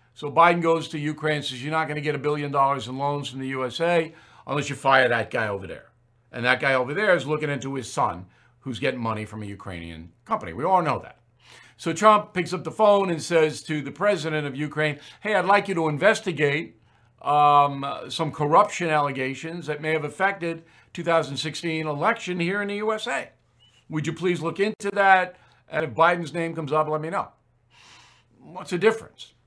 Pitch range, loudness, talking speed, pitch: 130-170 Hz, -24 LUFS, 200 wpm, 150 Hz